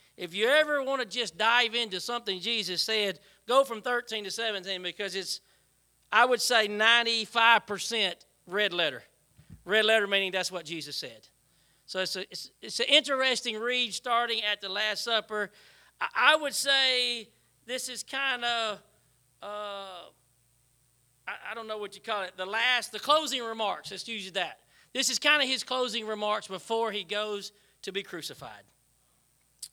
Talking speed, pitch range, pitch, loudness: 165 wpm, 190-235 Hz, 215 Hz, -28 LUFS